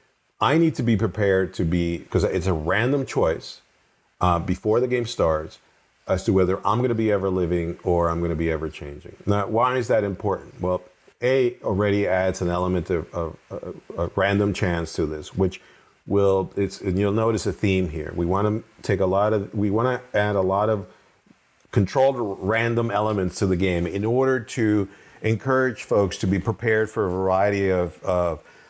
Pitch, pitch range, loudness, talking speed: 100 Hz, 90-110 Hz, -23 LUFS, 195 wpm